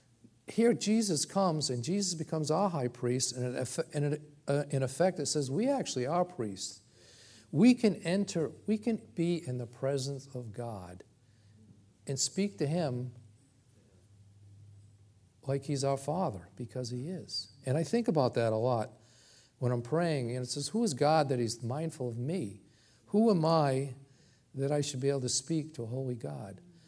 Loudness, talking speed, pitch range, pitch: -32 LUFS, 165 wpm, 120-160 Hz, 135 Hz